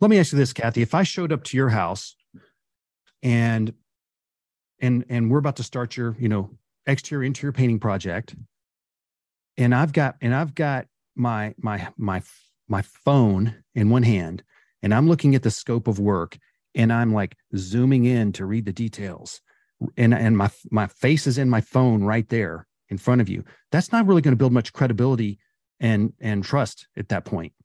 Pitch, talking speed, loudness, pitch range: 120 Hz, 190 wpm, -22 LUFS, 105-135 Hz